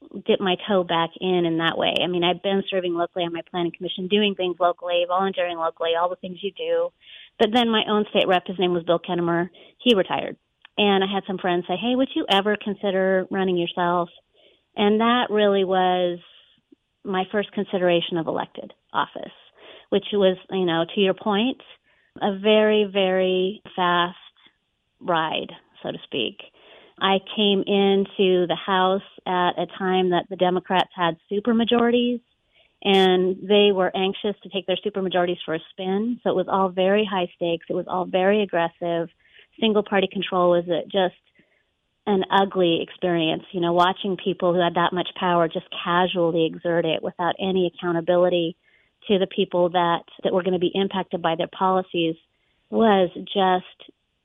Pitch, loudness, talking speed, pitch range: 185 Hz, -22 LUFS, 175 wpm, 175-200 Hz